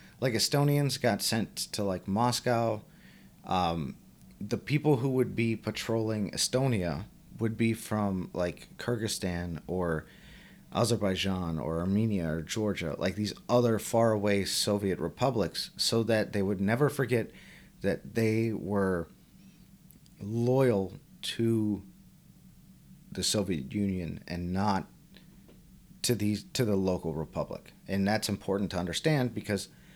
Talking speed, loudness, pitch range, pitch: 120 wpm, -30 LUFS, 95-120 Hz, 105 Hz